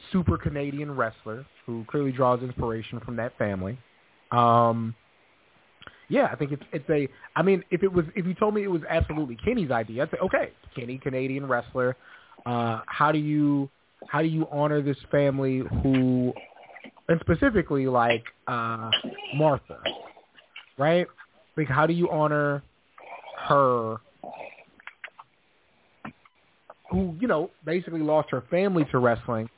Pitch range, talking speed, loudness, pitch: 120-155 Hz, 140 wpm, -26 LUFS, 140 Hz